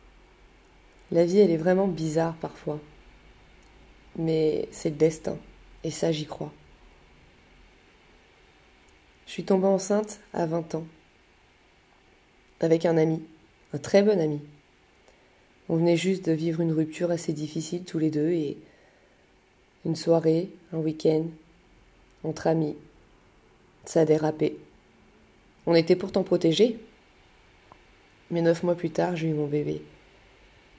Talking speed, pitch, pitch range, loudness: 125 wpm, 160 Hz, 110-170 Hz, -26 LUFS